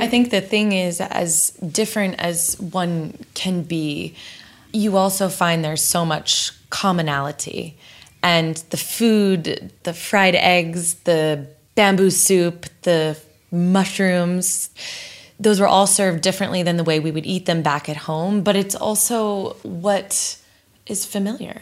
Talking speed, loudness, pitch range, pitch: 140 wpm, -19 LUFS, 165-195 Hz, 180 Hz